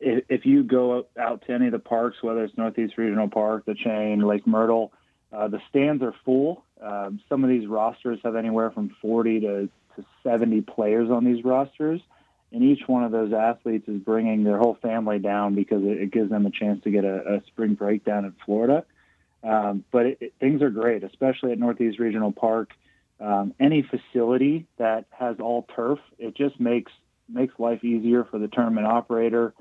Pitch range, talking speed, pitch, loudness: 105-125 Hz, 195 wpm, 115 Hz, -24 LUFS